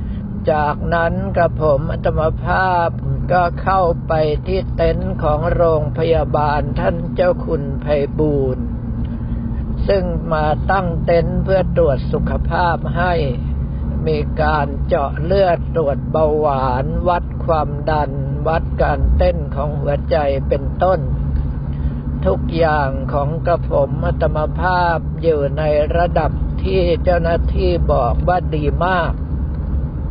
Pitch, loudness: 130 Hz, -18 LUFS